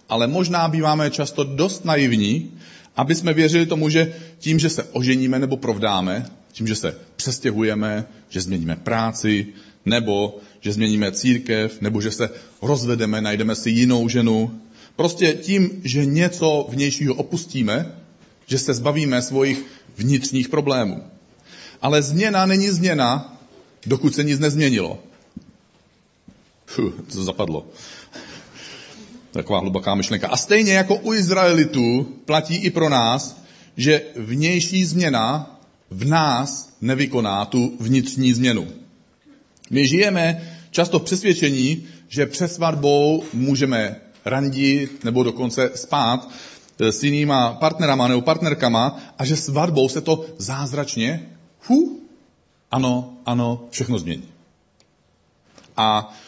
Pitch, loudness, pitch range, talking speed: 135 Hz, -20 LUFS, 115-160 Hz, 115 wpm